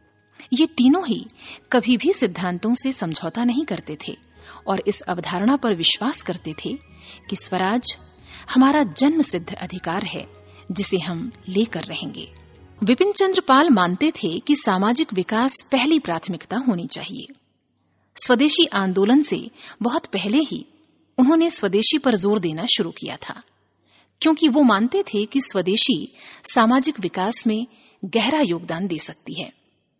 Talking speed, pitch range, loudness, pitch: 140 wpm, 185-275 Hz, -20 LUFS, 225 Hz